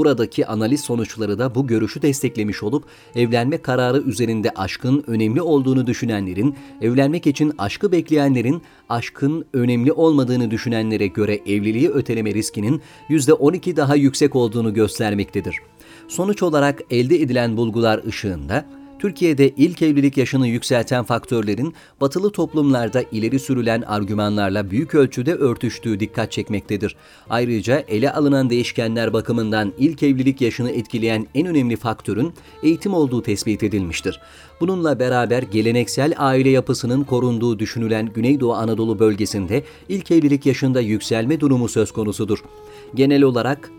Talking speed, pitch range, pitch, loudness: 120 wpm, 110-145 Hz, 125 Hz, -19 LUFS